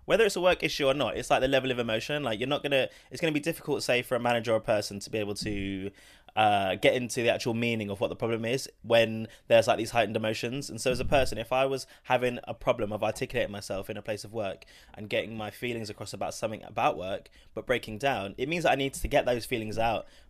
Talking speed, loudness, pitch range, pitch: 265 wpm, -29 LUFS, 110-135 Hz, 120 Hz